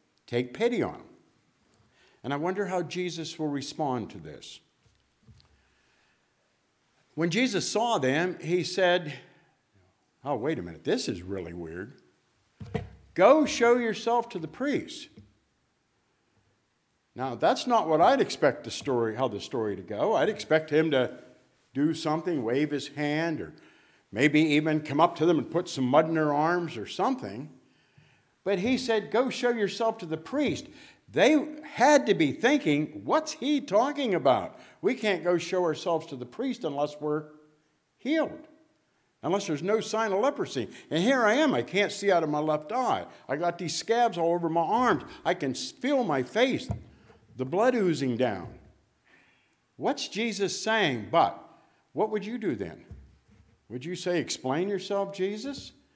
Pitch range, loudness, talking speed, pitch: 150-225 Hz, -27 LUFS, 160 wpm, 175 Hz